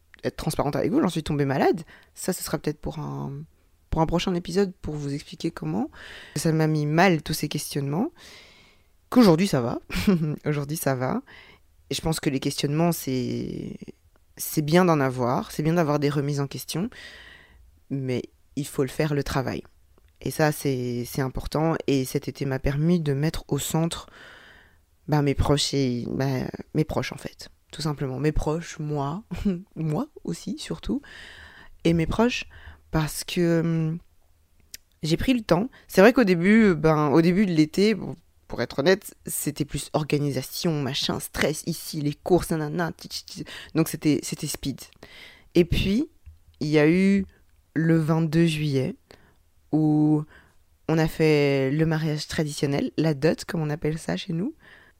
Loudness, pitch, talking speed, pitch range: -25 LUFS, 150 Hz, 165 wpm, 135-165 Hz